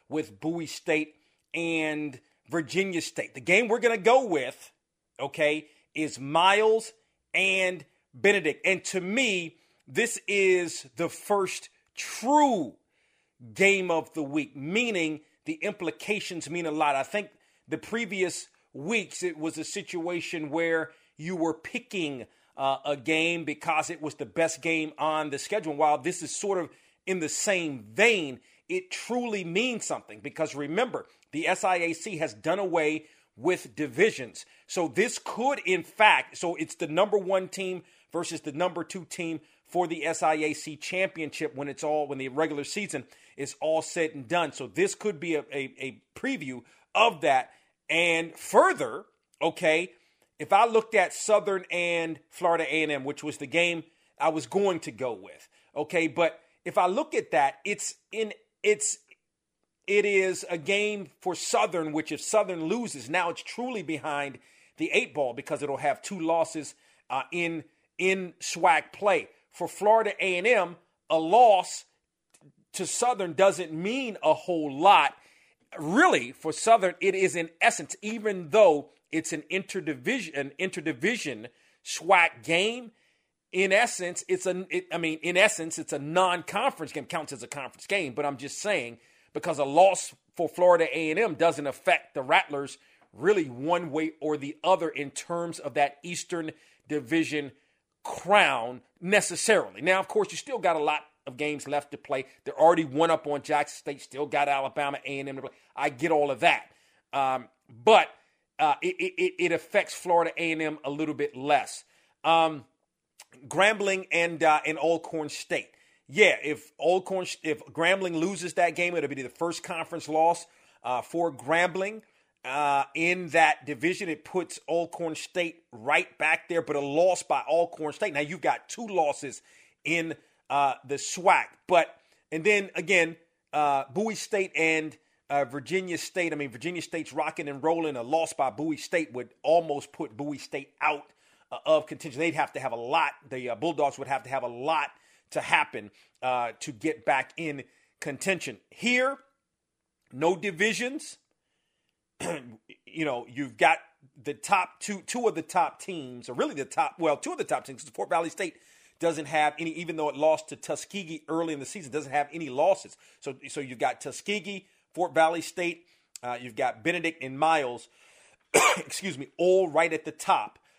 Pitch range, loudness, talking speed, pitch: 150-185 Hz, -27 LUFS, 165 wpm, 165 Hz